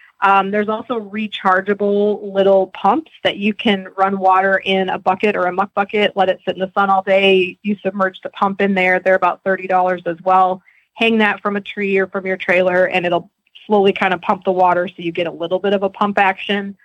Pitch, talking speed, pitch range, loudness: 195 Hz, 230 wpm, 185-205 Hz, -16 LUFS